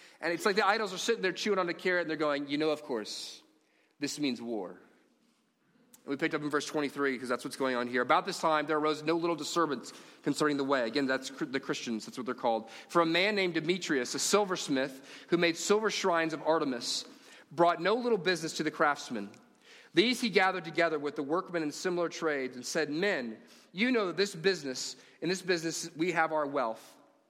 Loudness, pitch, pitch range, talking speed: -31 LUFS, 160 Hz, 145-185 Hz, 215 wpm